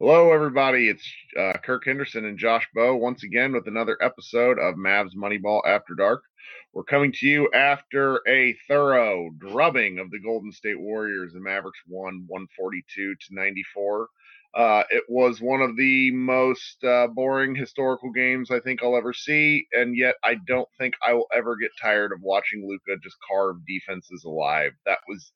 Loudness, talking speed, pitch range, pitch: -23 LUFS, 175 wpm, 100-130 Hz, 120 Hz